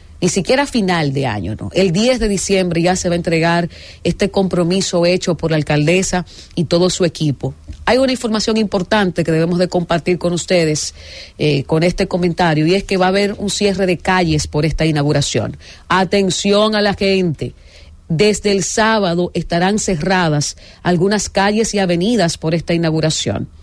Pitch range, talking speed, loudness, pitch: 160-195 Hz, 175 wpm, -16 LUFS, 180 Hz